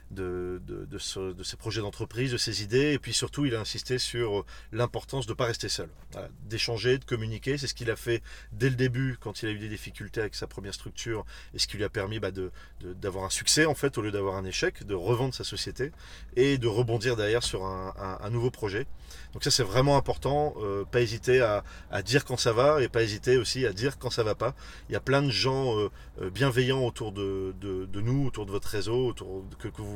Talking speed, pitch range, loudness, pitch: 250 wpm, 100-130 Hz, -29 LUFS, 115 Hz